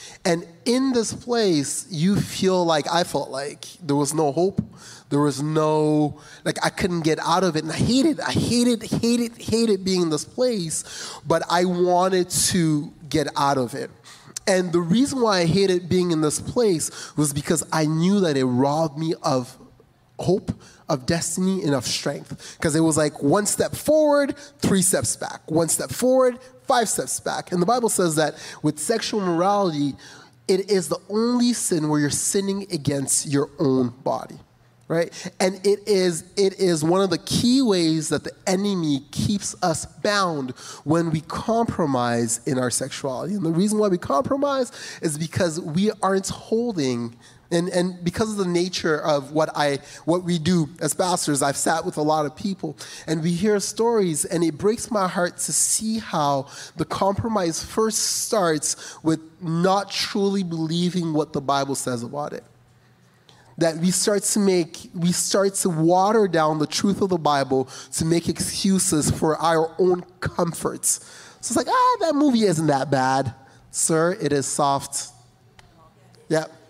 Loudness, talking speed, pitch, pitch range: -22 LUFS, 175 wpm, 170 Hz, 150-195 Hz